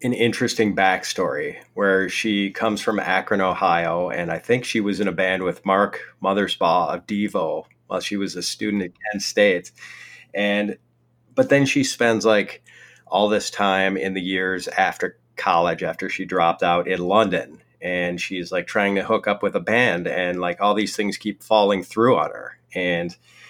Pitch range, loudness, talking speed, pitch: 95-105 Hz, -21 LUFS, 180 wpm, 100 Hz